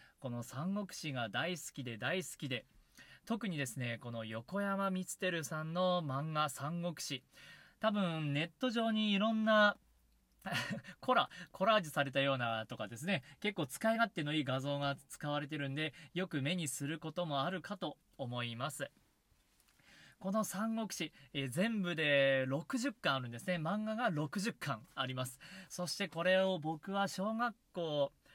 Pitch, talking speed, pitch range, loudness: 160 Hz, 280 characters per minute, 135-195 Hz, -37 LUFS